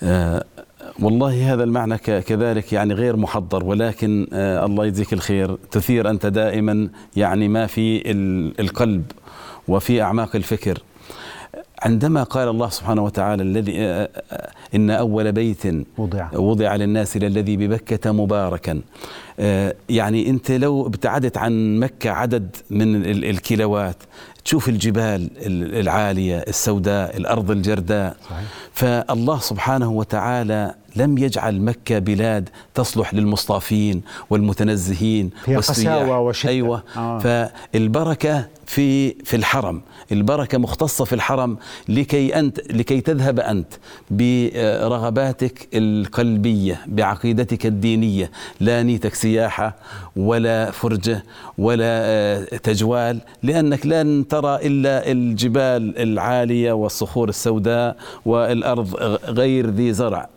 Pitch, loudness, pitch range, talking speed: 110 Hz, -20 LUFS, 105-120 Hz, 100 wpm